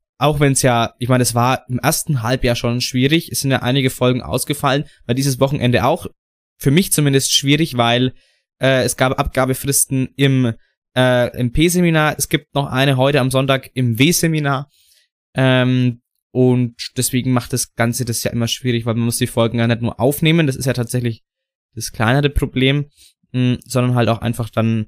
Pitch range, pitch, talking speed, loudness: 120-140 Hz, 130 Hz, 185 wpm, -17 LUFS